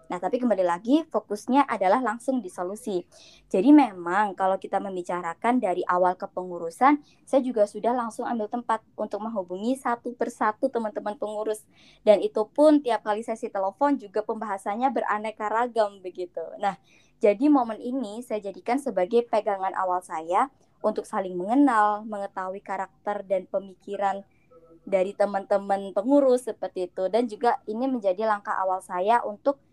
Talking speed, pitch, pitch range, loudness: 145 wpm, 210 Hz, 195-240 Hz, -26 LUFS